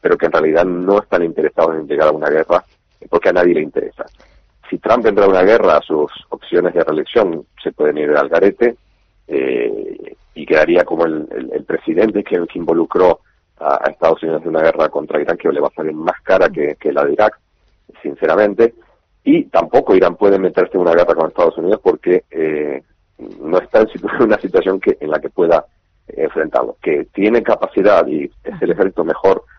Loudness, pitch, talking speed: -15 LUFS, 340 Hz, 200 wpm